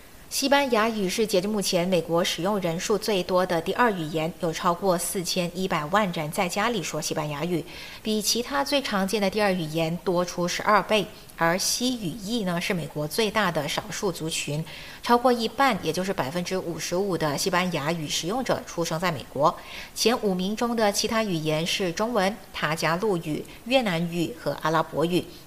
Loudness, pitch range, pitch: -25 LUFS, 165-210 Hz, 180 Hz